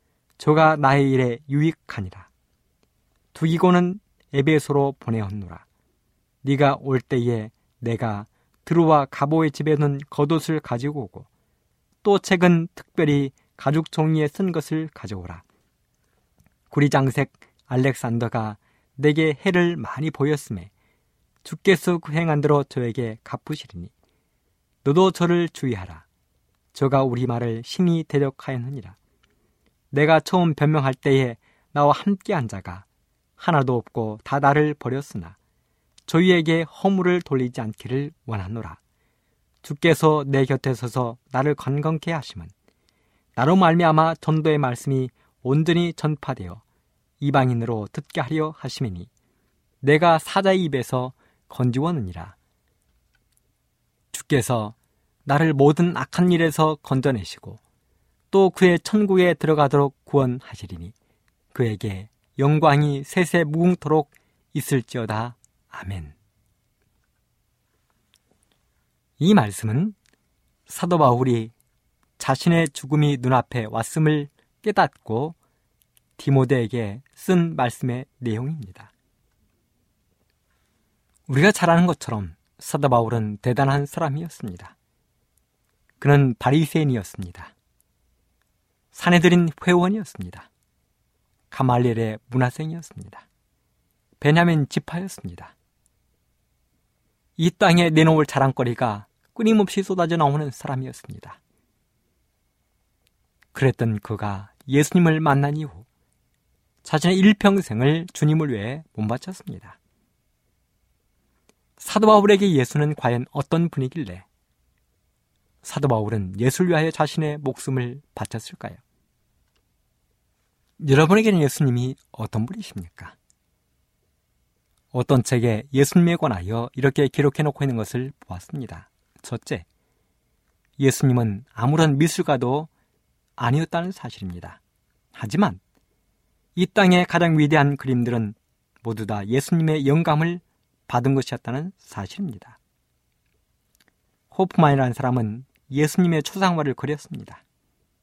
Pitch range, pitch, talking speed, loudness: 115-155 Hz, 135 Hz, 250 characters per minute, -21 LUFS